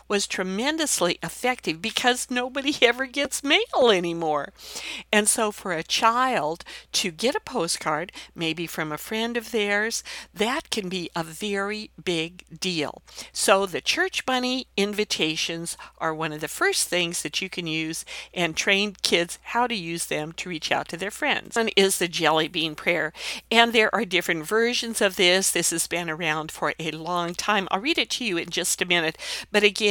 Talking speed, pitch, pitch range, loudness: 185 wpm, 190 Hz, 170-230 Hz, -24 LUFS